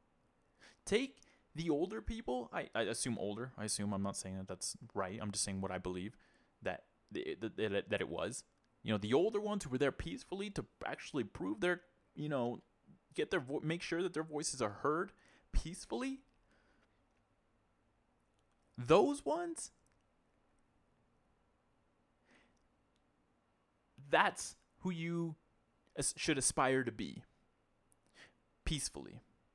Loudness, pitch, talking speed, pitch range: -39 LUFS, 135 Hz, 135 wpm, 105-170 Hz